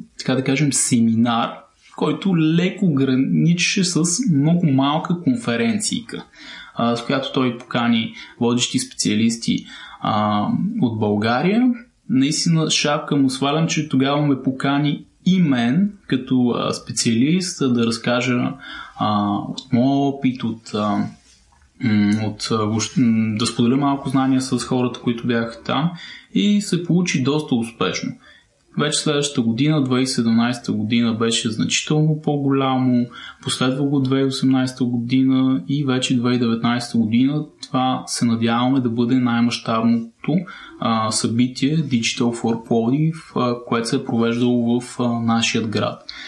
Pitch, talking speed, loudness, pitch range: 130 Hz, 110 wpm, -19 LUFS, 115-145 Hz